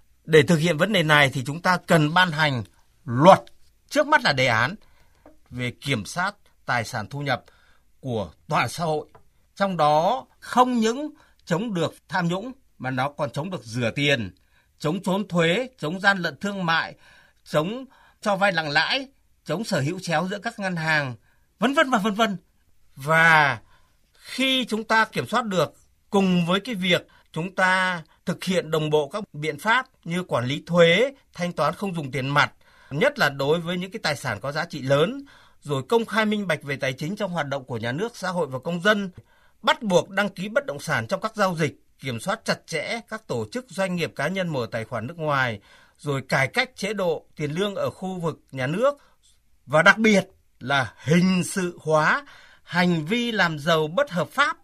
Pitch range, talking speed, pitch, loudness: 145-205 Hz, 200 wpm, 170 Hz, -23 LUFS